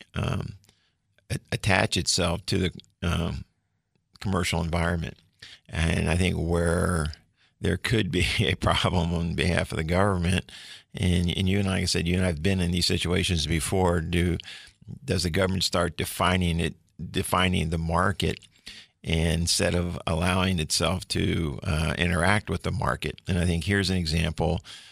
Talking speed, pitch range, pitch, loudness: 155 wpm, 85-95 Hz, 90 Hz, -26 LUFS